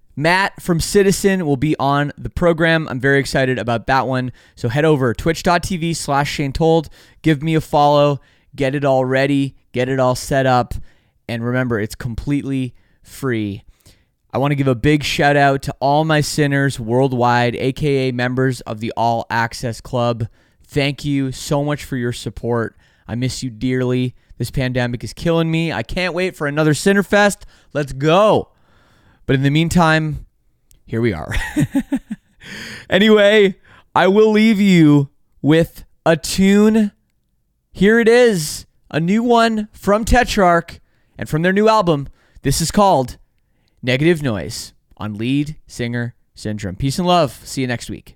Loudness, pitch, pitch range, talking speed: -17 LUFS, 140 Hz, 120-165 Hz, 160 wpm